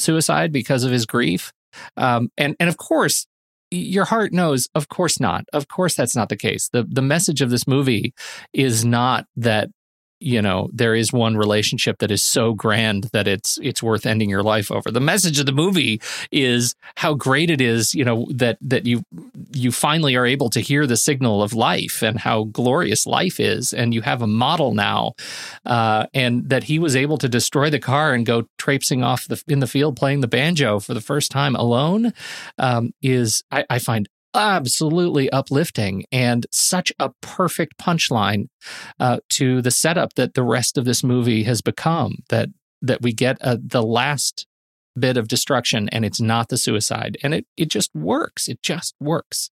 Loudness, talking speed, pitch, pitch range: -19 LUFS, 190 wpm, 125 Hz, 115-145 Hz